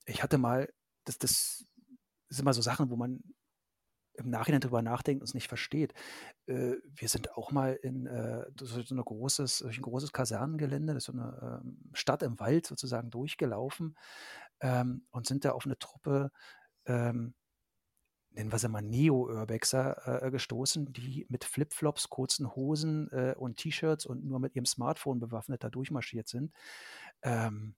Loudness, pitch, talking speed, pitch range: -34 LUFS, 130 Hz, 145 wpm, 120-145 Hz